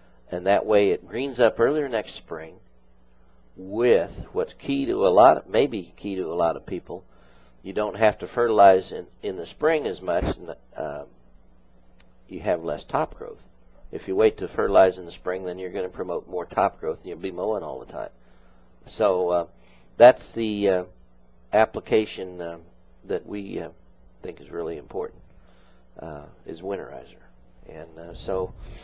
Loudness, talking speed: -24 LUFS, 175 wpm